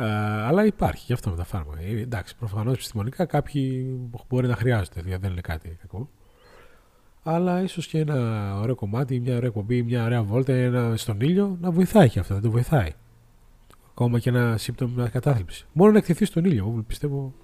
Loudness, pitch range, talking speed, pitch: -24 LUFS, 110-140 Hz, 180 wpm, 120 Hz